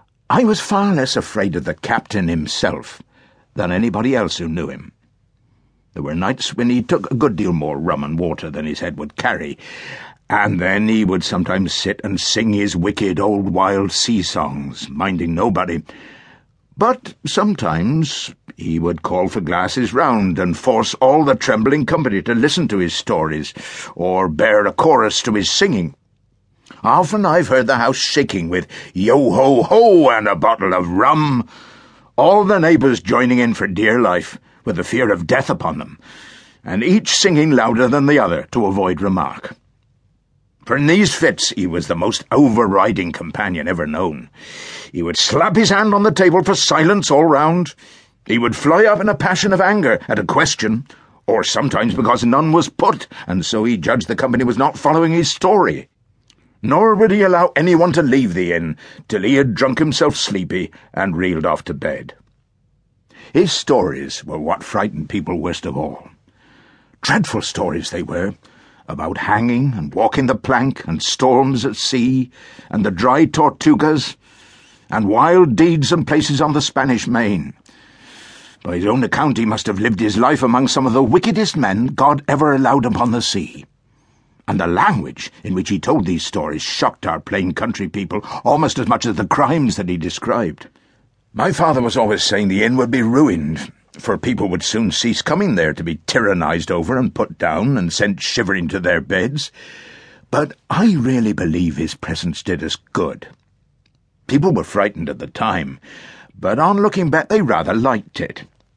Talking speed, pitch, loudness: 180 wpm, 130 Hz, -16 LUFS